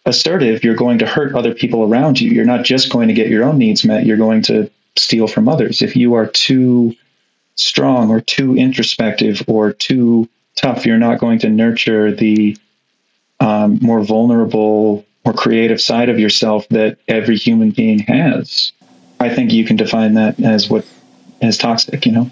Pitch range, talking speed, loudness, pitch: 110-120 Hz, 180 wpm, -13 LUFS, 115 Hz